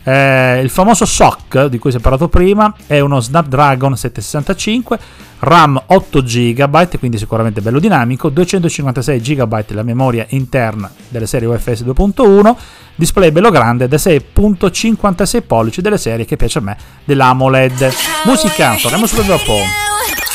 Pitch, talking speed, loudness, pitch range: 140 Hz, 140 wpm, -11 LUFS, 125-190 Hz